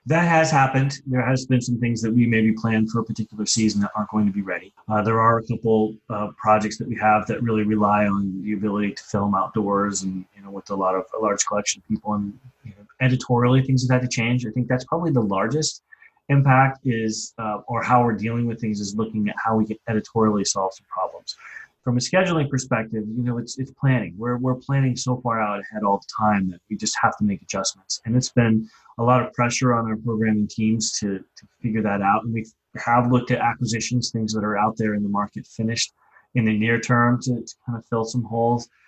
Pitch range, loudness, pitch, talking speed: 105-125 Hz, -22 LUFS, 115 Hz, 240 wpm